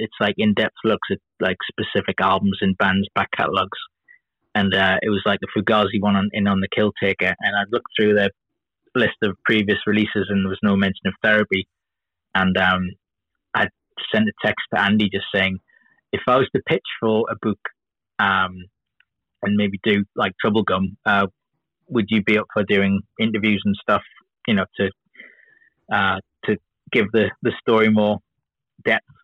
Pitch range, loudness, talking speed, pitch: 95-110 Hz, -20 LUFS, 180 wpm, 100 Hz